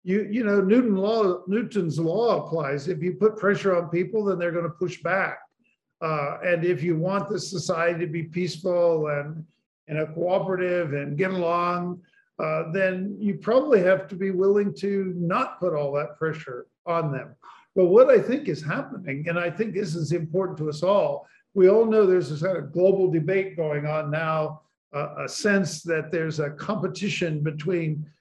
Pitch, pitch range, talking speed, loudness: 180 Hz, 160-195 Hz, 185 wpm, -24 LUFS